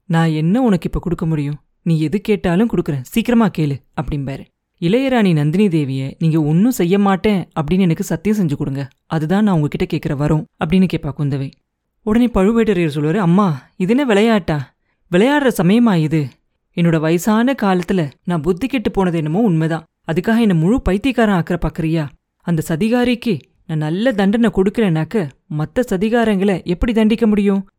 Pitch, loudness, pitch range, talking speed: 185 Hz, -17 LUFS, 160-215 Hz, 145 wpm